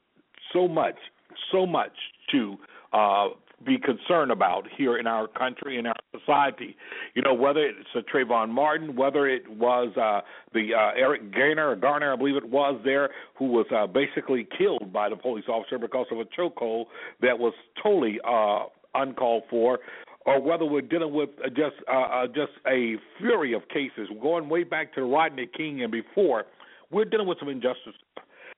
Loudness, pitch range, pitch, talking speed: -26 LUFS, 125-180 Hz, 145 Hz, 175 wpm